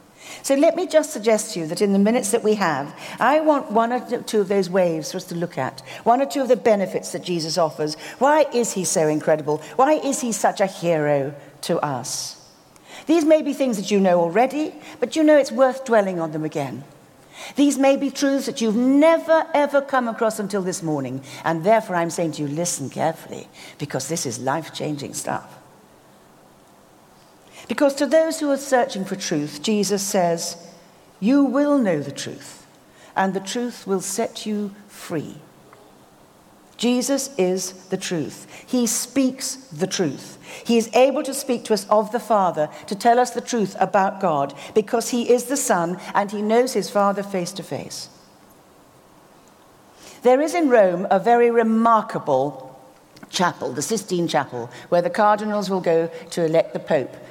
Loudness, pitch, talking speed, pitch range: -21 LUFS, 210 Hz, 180 wpm, 170-250 Hz